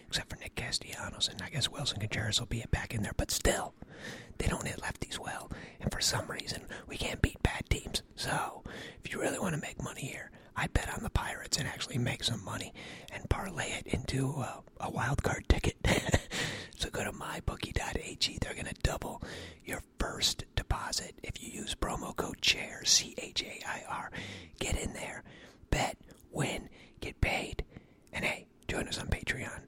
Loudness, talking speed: -35 LUFS, 185 wpm